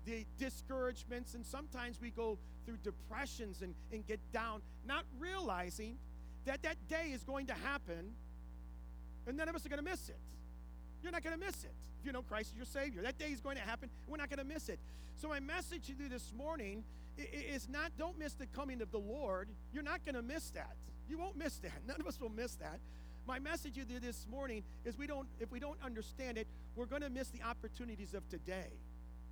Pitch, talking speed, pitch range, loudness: 245 Hz, 225 wpm, 185-285 Hz, -46 LUFS